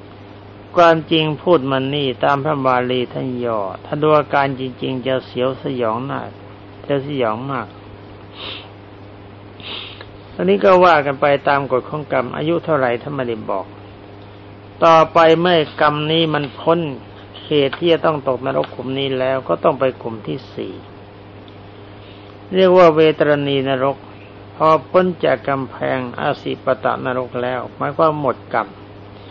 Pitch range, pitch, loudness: 100-150 Hz, 130 Hz, -17 LUFS